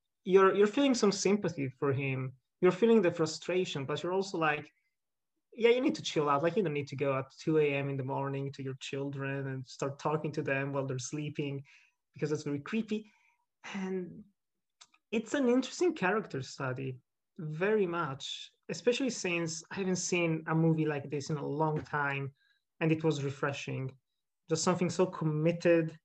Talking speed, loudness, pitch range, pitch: 180 wpm, -32 LUFS, 140-195 Hz, 160 Hz